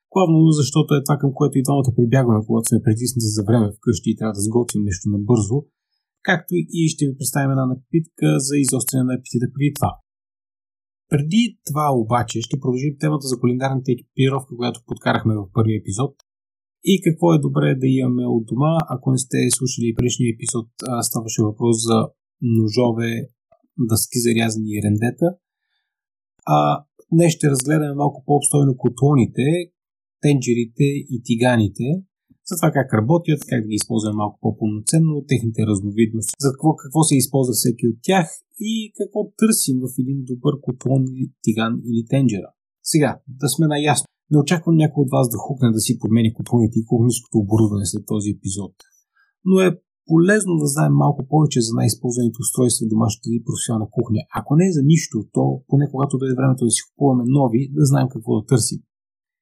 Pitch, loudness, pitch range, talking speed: 130 Hz, -19 LUFS, 115-150 Hz, 170 wpm